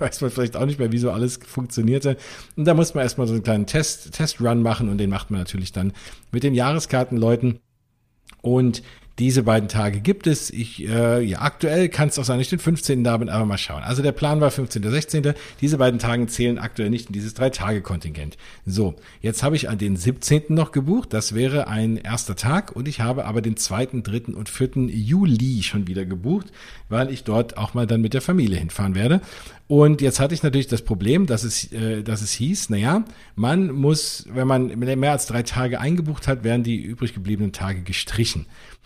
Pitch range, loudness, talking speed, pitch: 110-140 Hz, -22 LUFS, 210 wpm, 120 Hz